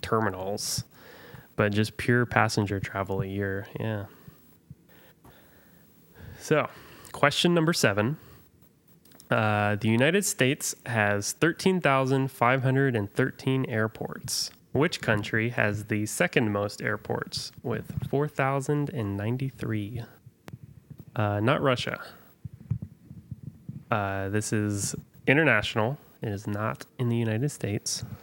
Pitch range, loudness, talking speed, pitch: 105-135 Hz, -27 LUFS, 90 wpm, 115 Hz